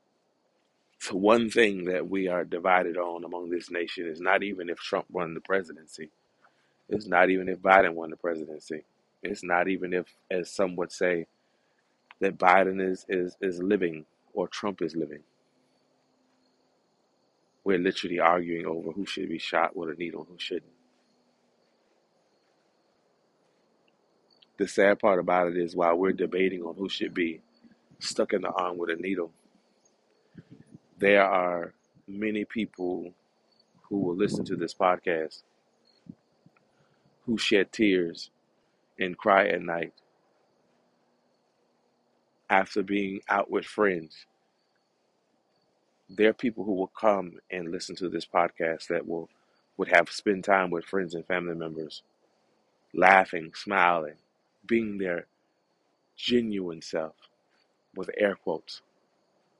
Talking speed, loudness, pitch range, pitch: 135 wpm, -27 LUFS, 85-95 Hz, 90 Hz